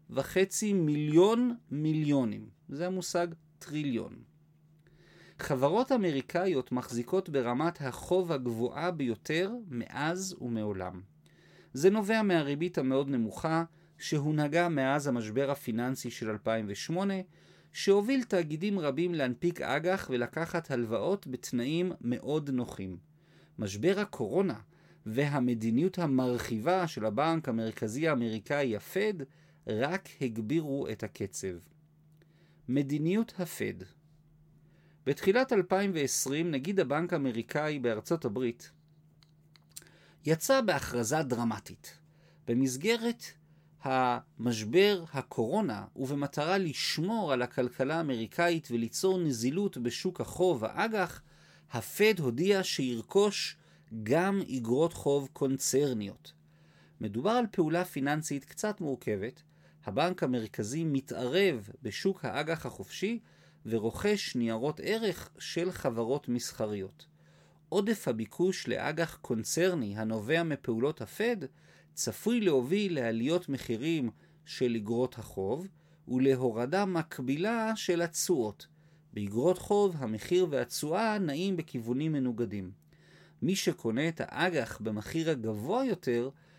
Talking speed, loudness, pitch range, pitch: 90 wpm, -31 LUFS, 125-175 Hz, 155 Hz